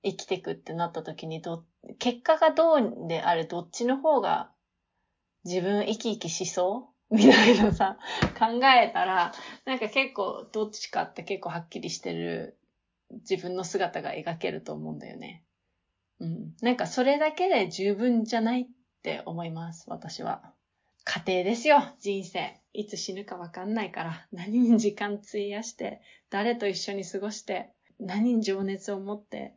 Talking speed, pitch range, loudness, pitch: 300 characters per minute, 175-235 Hz, -27 LUFS, 205 Hz